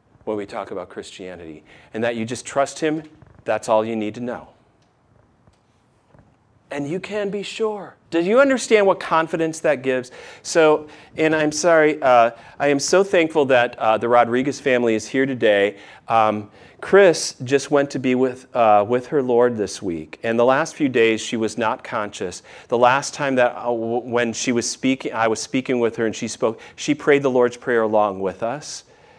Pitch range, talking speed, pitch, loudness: 115-150 Hz, 190 wpm, 125 Hz, -20 LUFS